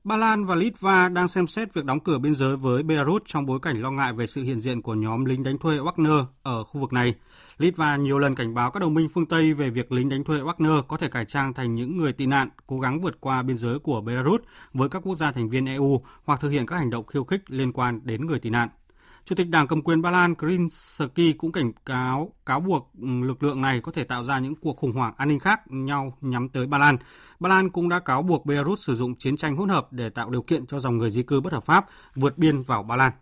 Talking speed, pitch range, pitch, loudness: 270 wpm, 130-160 Hz, 140 Hz, -24 LUFS